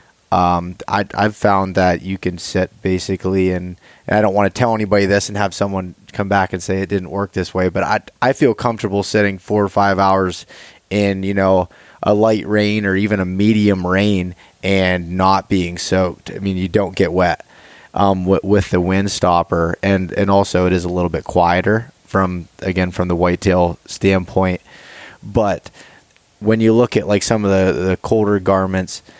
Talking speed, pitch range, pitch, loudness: 195 wpm, 90-100 Hz, 95 Hz, -17 LUFS